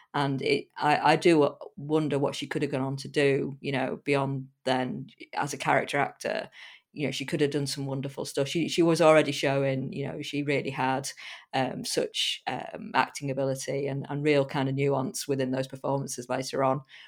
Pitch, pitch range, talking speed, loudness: 140 Hz, 135-145 Hz, 200 wpm, -28 LUFS